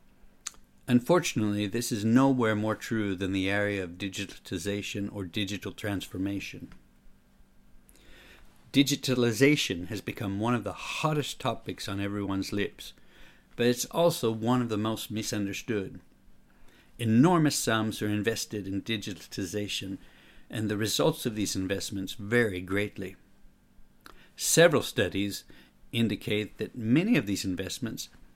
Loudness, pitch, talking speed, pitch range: -29 LUFS, 105 Hz, 115 wpm, 95-115 Hz